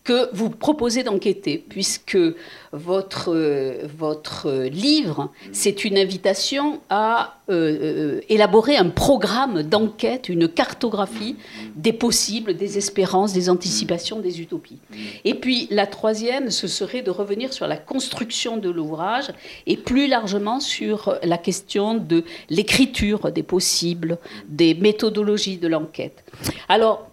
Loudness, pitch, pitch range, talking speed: -21 LUFS, 205 Hz, 180-235 Hz, 120 wpm